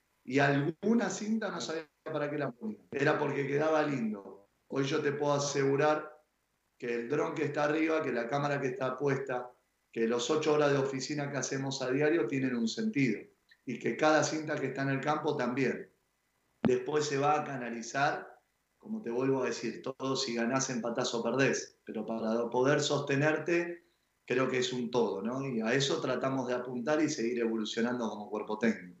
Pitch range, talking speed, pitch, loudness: 125-150 Hz, 190 wpm, 135 Hz, -32 LUFS